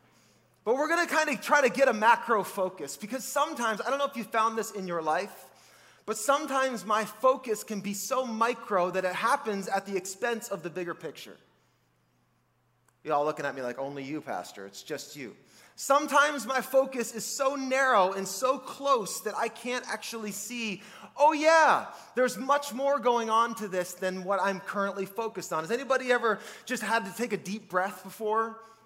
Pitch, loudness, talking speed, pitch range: 225 Hz, -28 LUFS, 195 wpm, 195-260 Hz